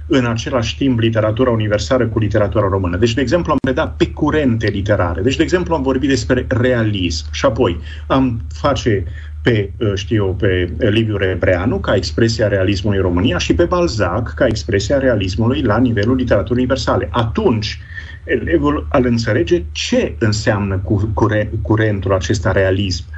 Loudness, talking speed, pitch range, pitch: -16 LUFS, 150 wpm, 95-125 Hz, 110 Hz